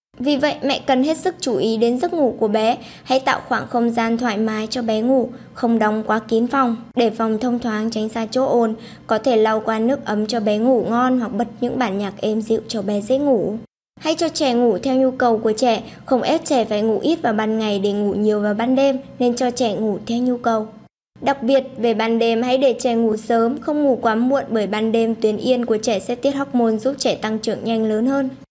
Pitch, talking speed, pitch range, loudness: 235 Hz, 250 wpm, 220-255 Hz, -19 LUFS